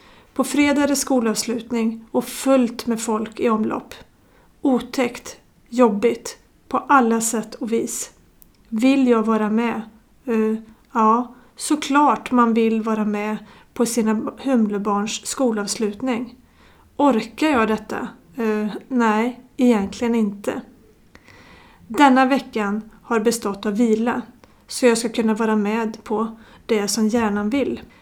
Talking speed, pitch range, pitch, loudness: 120 wpm, 220-250 Hz, 230 Hz, -20 LUFS